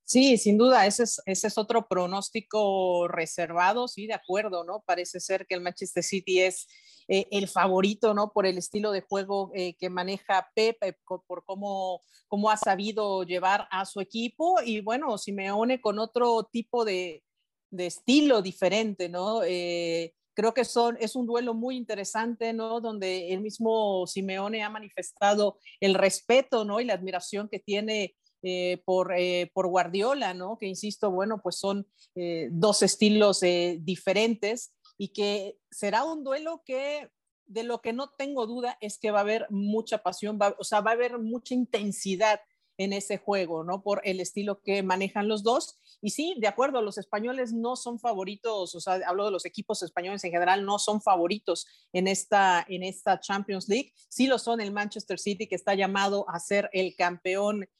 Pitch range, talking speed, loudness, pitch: 185-225 Hz, 180 wpm, -28 LUFS, 205 Hz